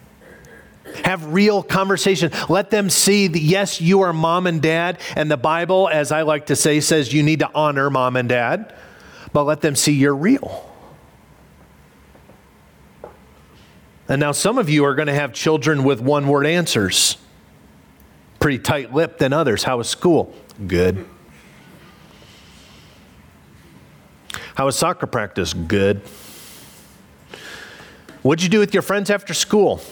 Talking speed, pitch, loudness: 140 wpm, 150 Hz, -18 LUFS